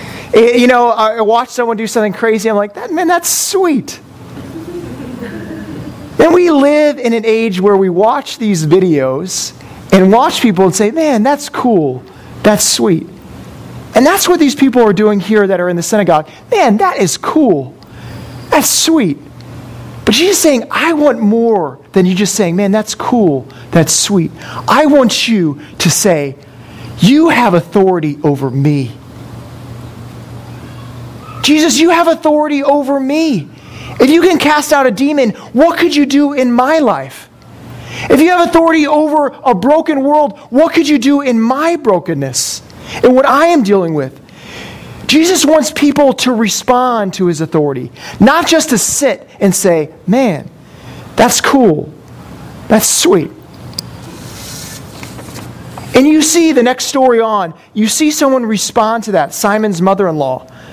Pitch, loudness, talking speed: 225 Hz, -10 LUFS, 150 wpm